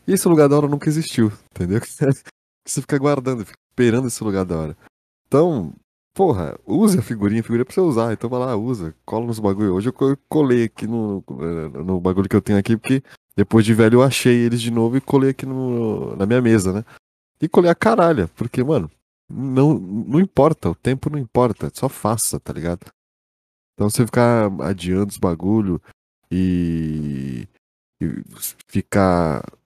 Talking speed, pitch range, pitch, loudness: 180 wpm, 100-130 Hz, 115 Hz, -19 LUFS